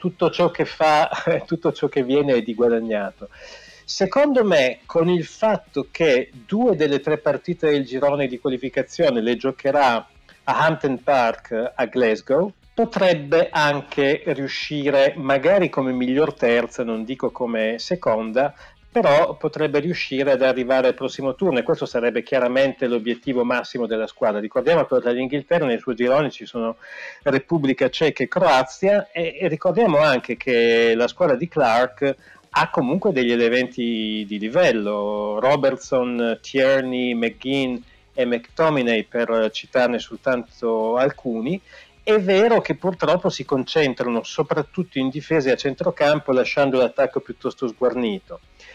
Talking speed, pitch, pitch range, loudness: 140 wpm, 135 Hz, 120-160 Hz, -20 LUFS